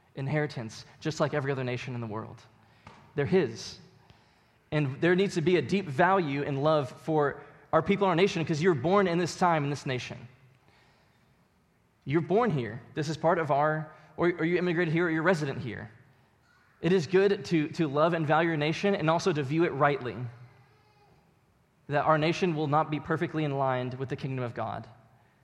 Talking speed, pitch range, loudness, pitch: 195 wpm, 130-170 Hz, -28 LUFS, 150 Hz